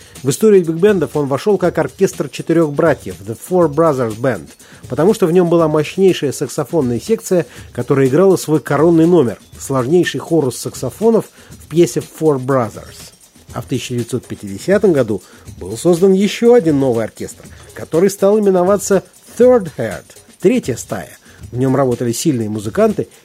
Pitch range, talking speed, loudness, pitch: 125-185 Hz, 140 wpm, -15 LUFS, 155 Hz